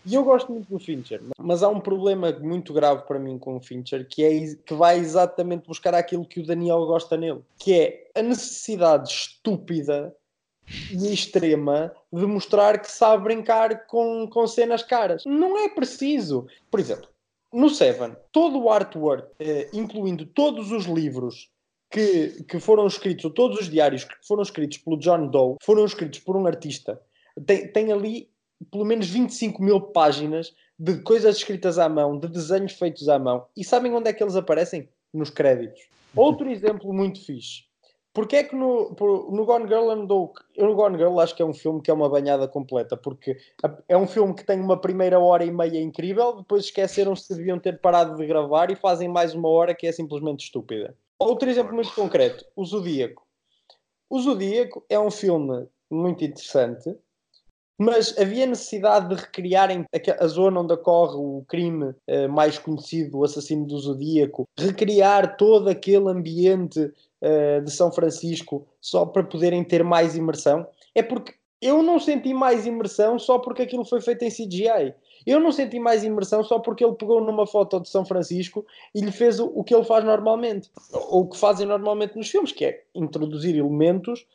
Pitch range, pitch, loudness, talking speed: 160-220 Hz, 190 Hz, -22 LUFS, 180 wpm